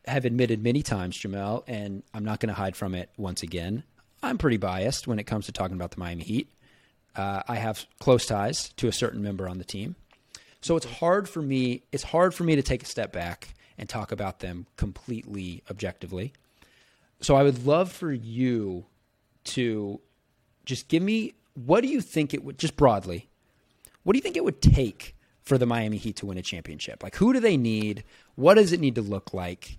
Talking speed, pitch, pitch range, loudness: 210 wpm, 110 Hz, 100-135 Hz, -27 LUFS